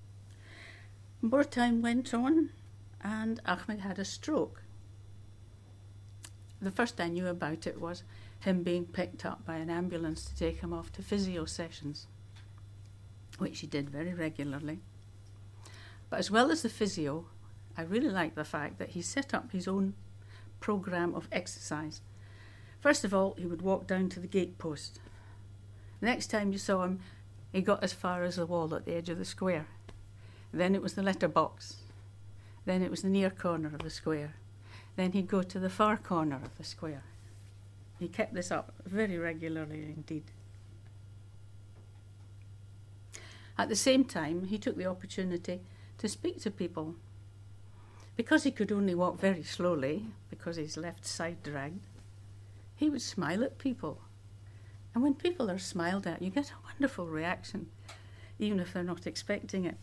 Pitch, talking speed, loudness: 155 Hz, 165 wpm, -34 LUFS